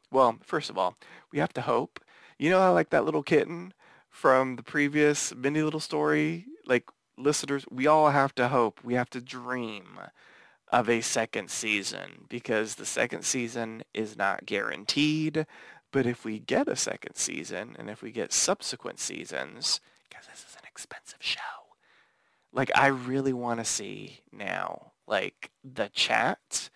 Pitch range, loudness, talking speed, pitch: 120-150 Hz, -28 LUFS, 160 wpm, 135 Hz